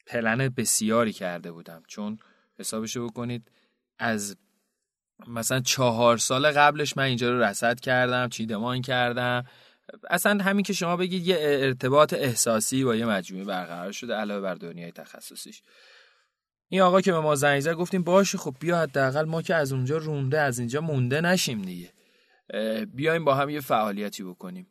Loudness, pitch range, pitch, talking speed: -25 LUFS, 110-150 Hz, 125 Hz, 160 wpm